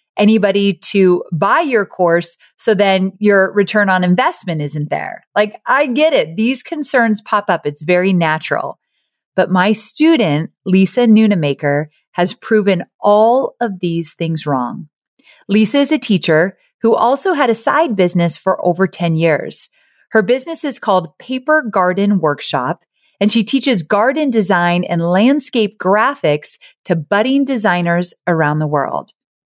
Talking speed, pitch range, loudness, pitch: 145 wpm, 170-225 Hz, -15 LUFS, 195 Hz